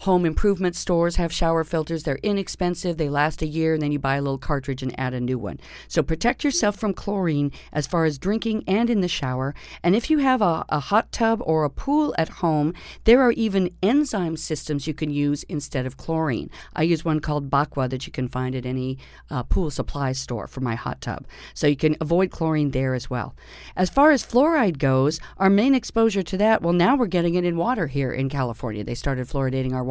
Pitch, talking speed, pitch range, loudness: 160 Hz, 225 wpm, 135-190 Hz, -23 LUFS